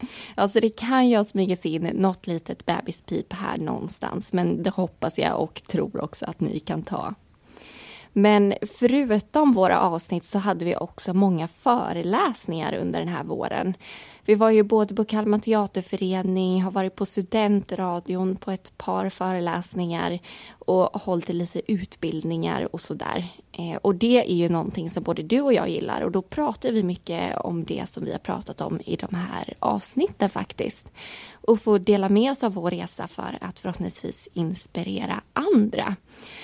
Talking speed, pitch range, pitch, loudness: 165 wpm, 180-215 Hz, 195 Hz, -24 LUFS